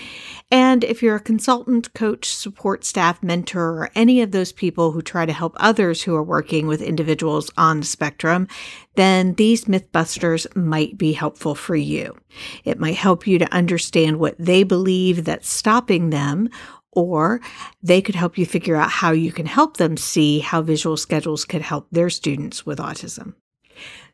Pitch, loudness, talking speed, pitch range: 175 Hz, -19 LUFS, 170 wpm, 160-205 Hz